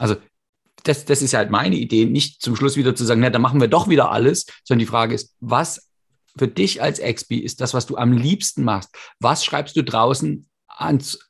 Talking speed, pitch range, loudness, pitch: 220 wpm, 115-145 Hz, -19 LUFS, 125 Hz